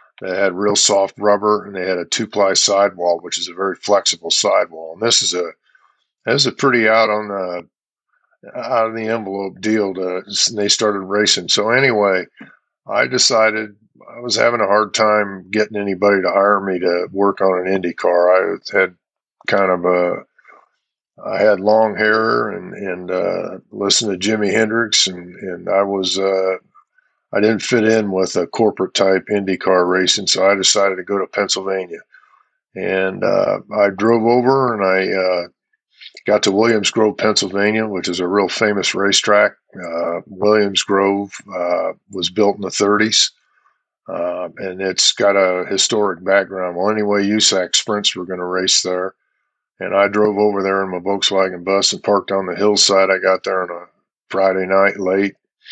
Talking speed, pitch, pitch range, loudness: 180 wpm, 100 Hz, 95-105 Hz, -16 LUFS